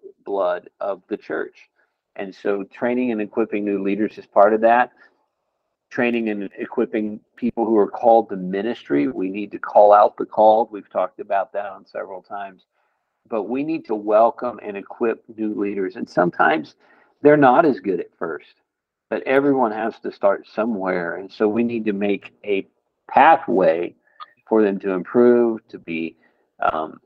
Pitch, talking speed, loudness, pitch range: 110 Hz, 170 wpm, -20 LUFS, 100-120 Hz